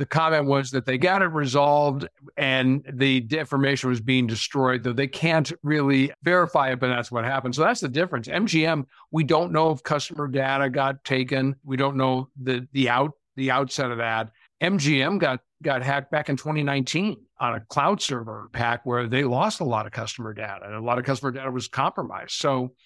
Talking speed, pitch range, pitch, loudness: 215 wpm, 125-150 Hz, 135 Hz, -24 LUFS